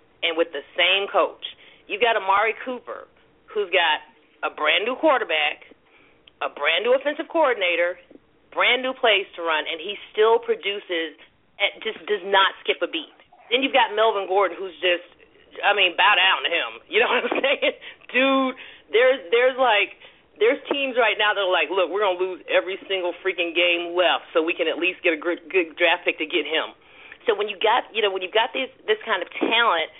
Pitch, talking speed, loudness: 215 Hz, 205 wpm, -21 LUFS